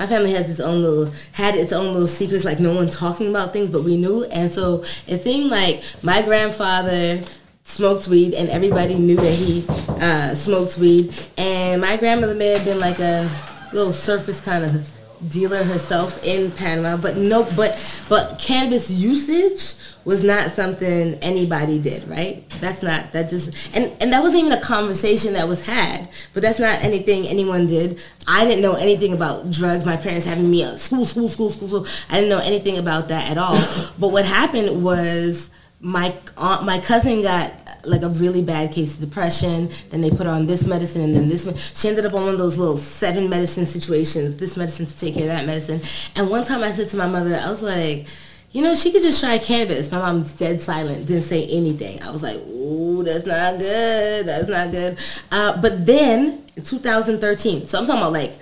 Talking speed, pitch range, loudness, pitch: 205 wpm, 170-205 Hz, -19 LUFS, 180 Hz